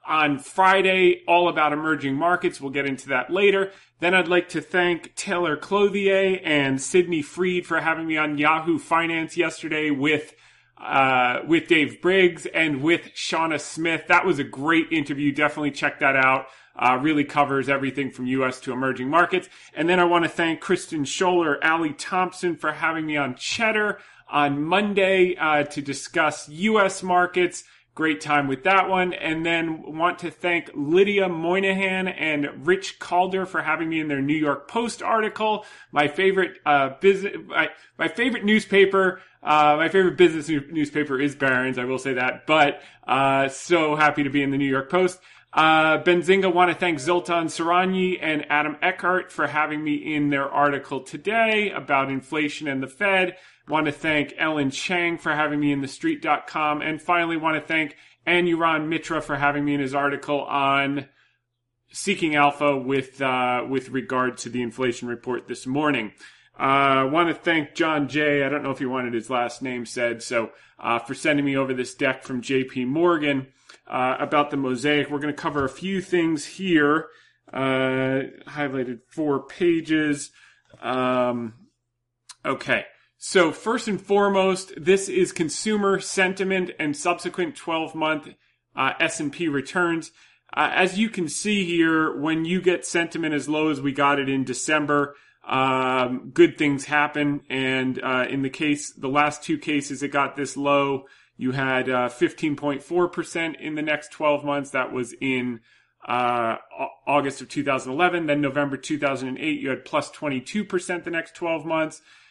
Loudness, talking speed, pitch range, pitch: -22 LUFS, 170 wpm, 140-175 Hz, 155 Hz